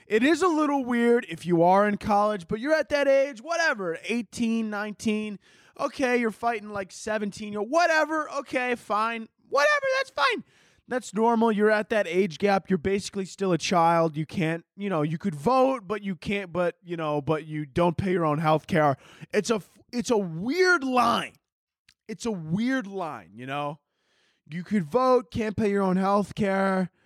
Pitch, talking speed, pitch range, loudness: 210 Hz, 185 wpm, 180-240 Hz, -25 LUFS